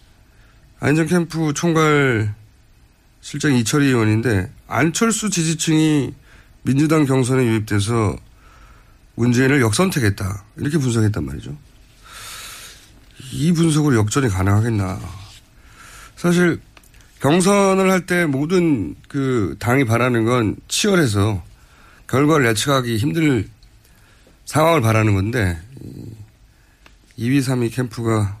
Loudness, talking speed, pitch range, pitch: -18 LUFS, 225 characters per minute, 110-150 Hz, 125 Hz